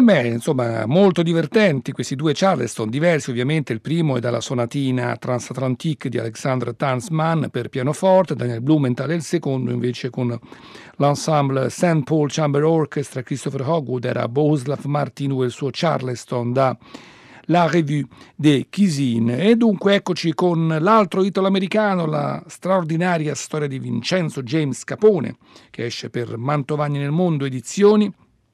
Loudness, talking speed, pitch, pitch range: -20 LUFS, 135 wpm, 145 Hz, 125-170 Hz